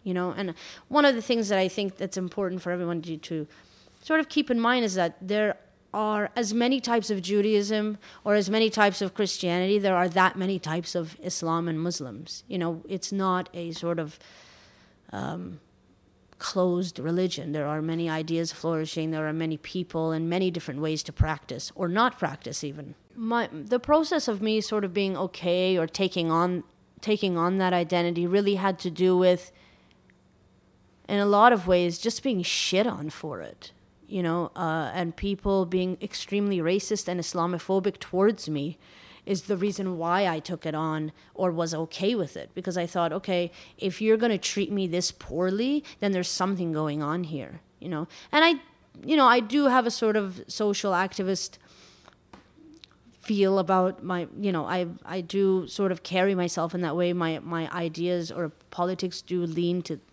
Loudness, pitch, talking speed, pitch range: -27 LUFS, 180 Hz, 185 wpm, 165-205 Hz